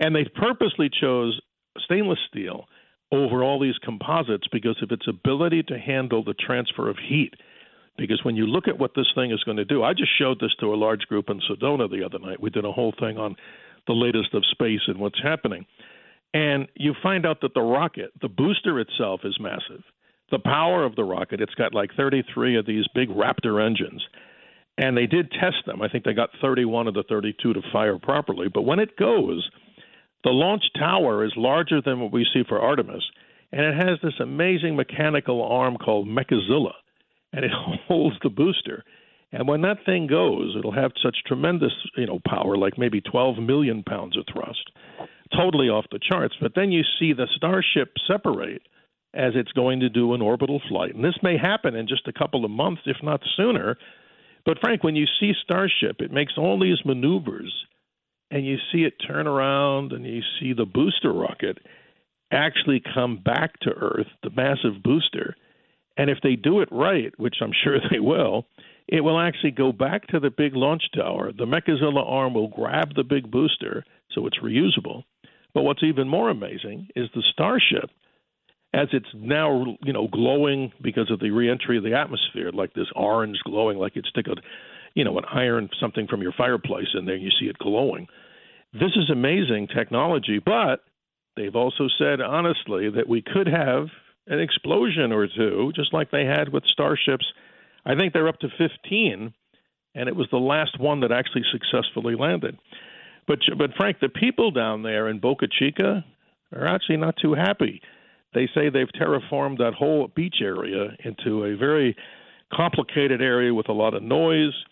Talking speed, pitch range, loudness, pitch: 185 wpm, 115-155 Hz, -23 LUFS, 135 Hz